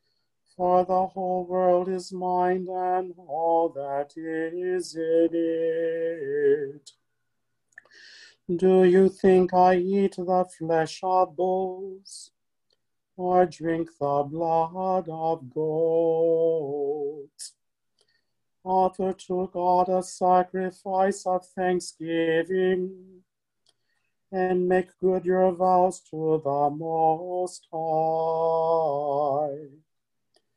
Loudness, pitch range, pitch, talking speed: -25 LUFS, 165-185 Hz, 180 Hz, 85 wpm